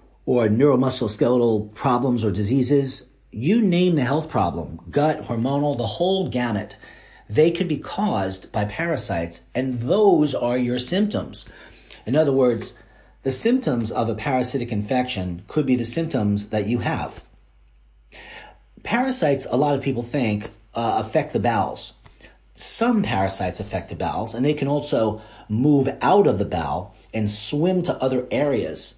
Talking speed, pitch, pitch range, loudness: 145 wpm, 120 Hz, 105-145 Hz, -22 LUFS